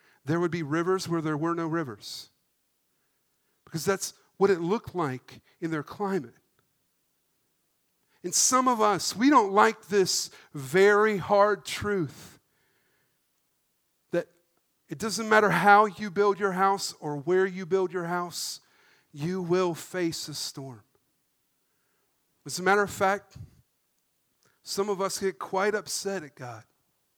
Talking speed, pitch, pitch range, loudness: 135 wpm, 185 Hz, 160-200 Hz, -26 LUFS